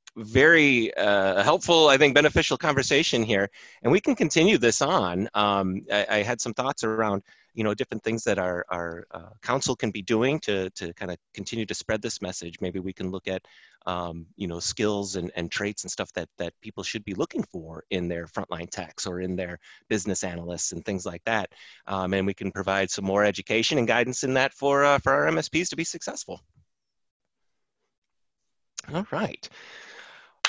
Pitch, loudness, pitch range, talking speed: 100 Hz, -25 LUFS, 95-120 Hz, 195 wpm